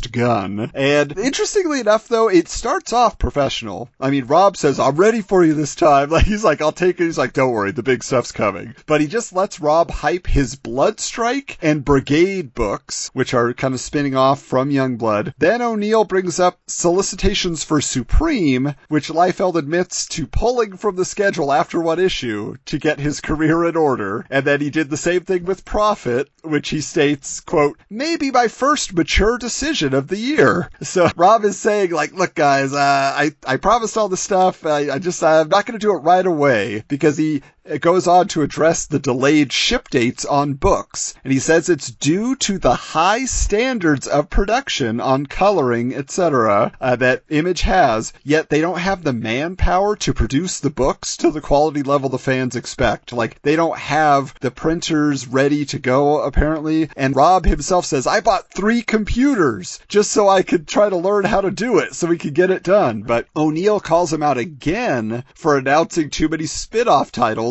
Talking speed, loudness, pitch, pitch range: 195 wpm, -17 LUFS, 155 Hz, 140-185 Hz